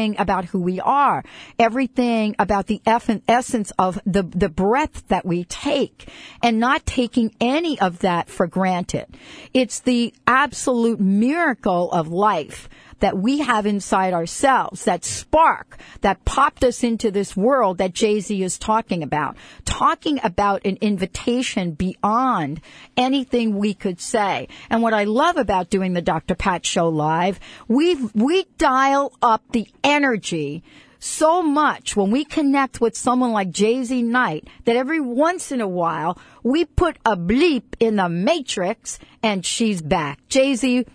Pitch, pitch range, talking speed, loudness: 220 Hz, 190-260 Hz, 150 wpm, -20 LUFS